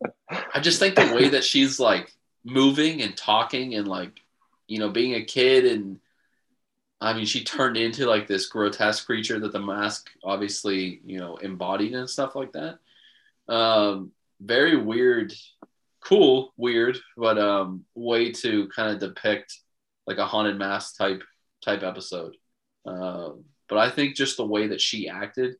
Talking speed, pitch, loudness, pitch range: 160 wpm, 110 Hz, -23 LUFS, 100-140 Hz